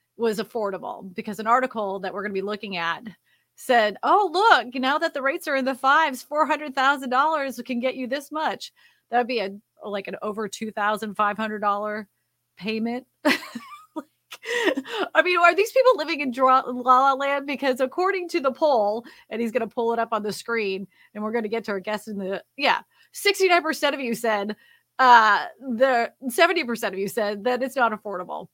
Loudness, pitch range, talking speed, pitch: -23 LUFS, 215-285 Hz, 210 wpm, 245 Hz